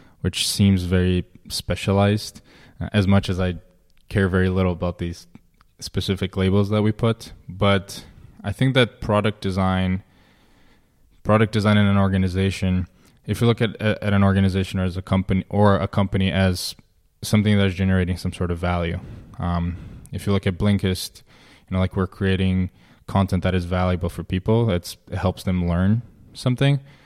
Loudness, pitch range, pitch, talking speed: -22 LUFS, 90-105 Hz, 95 Hz, 160 wpm